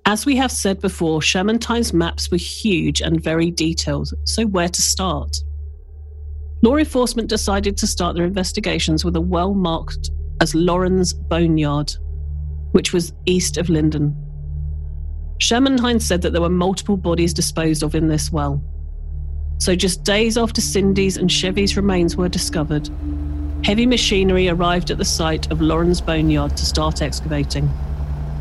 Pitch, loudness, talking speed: 155 Hz, -19 LUFS, 145 wpm